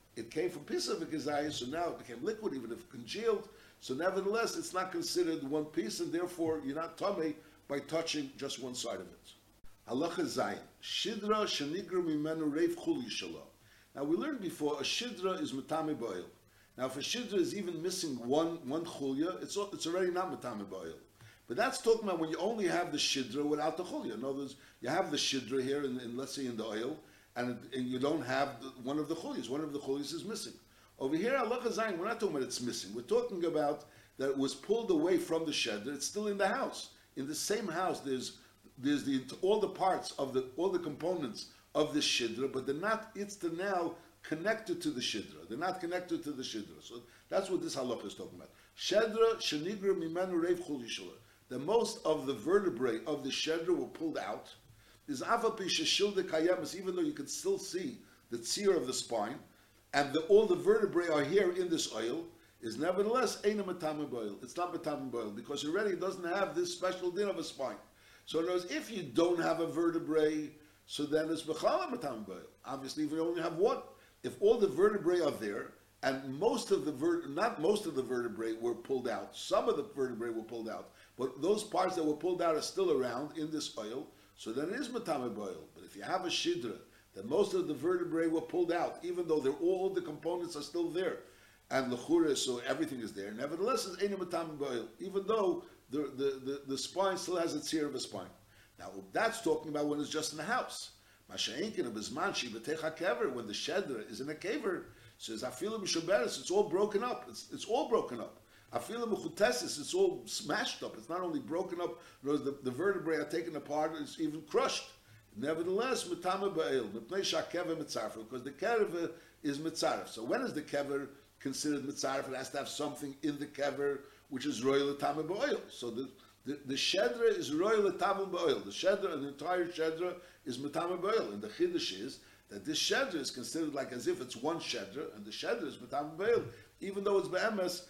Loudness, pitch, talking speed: -35 LUFS, 170 Hz, 195 wpm